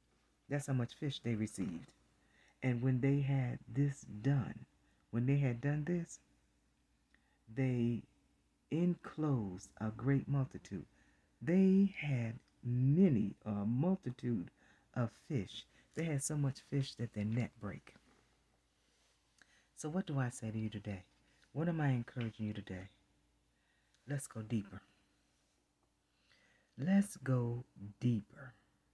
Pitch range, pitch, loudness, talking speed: 105-140 Hz, 120 Hz, -38 LUFS, 120 wpm